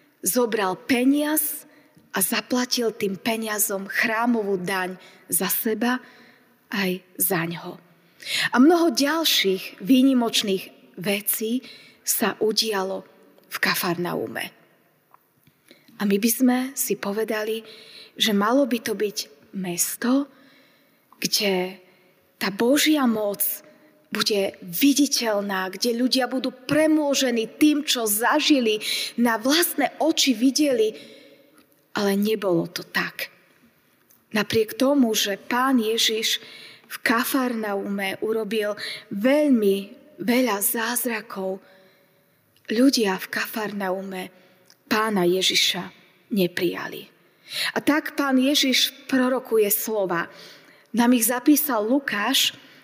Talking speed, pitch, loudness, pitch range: 95 wpm, 225 Hz, -22 LUFS, 195-260 Hz